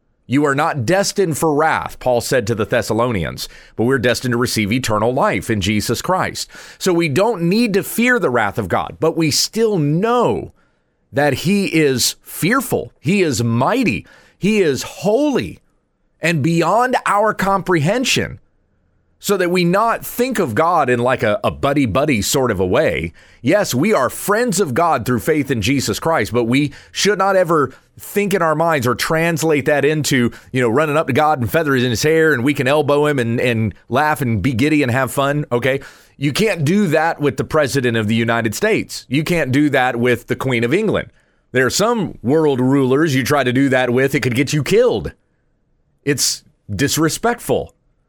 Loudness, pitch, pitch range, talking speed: -16 LUFS, 145 Hz, 125-165 Hz, 190 wpm